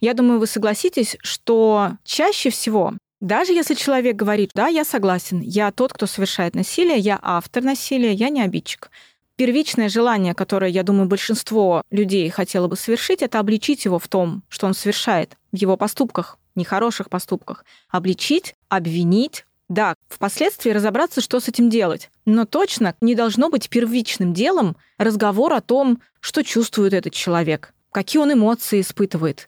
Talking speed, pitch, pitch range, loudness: 155 wpm, 215 Hz, 190-245 Hz, -19 LUFS